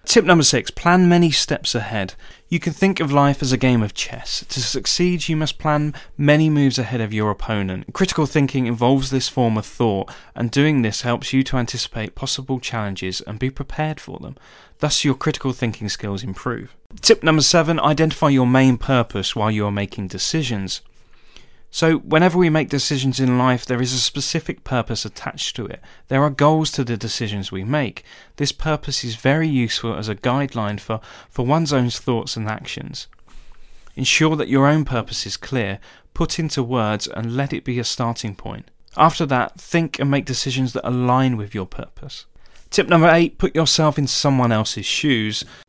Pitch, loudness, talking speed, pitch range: 130 Hz, -19 LUFS, 185 wpm, 115-150 Hz